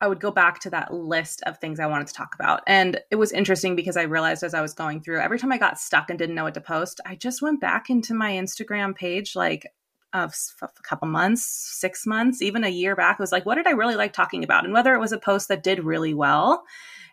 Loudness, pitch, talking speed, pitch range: -23 LUFS, 190 Hz, 270 wpm, 165-215 Hz